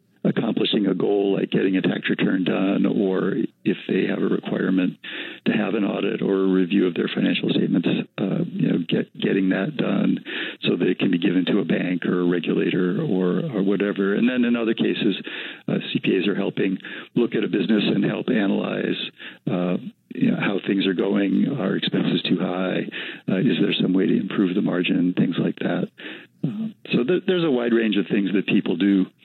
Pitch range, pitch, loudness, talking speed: 90-110 Hz, 95 Hz, -22 LUFS, 200 wpm